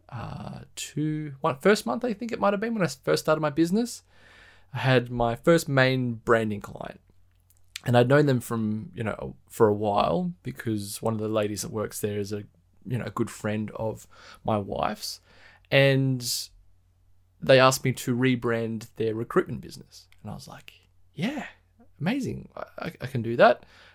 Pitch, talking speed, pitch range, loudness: 115 Hz, 185 wpm, 105-135 Hz, -26 LUFS